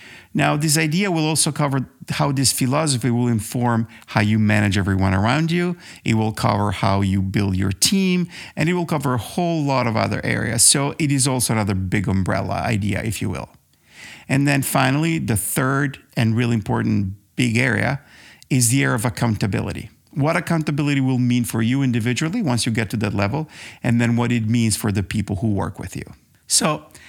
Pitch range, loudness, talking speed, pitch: 105-140 Hz, -20 LUFS, 195 wpm, 120 Hz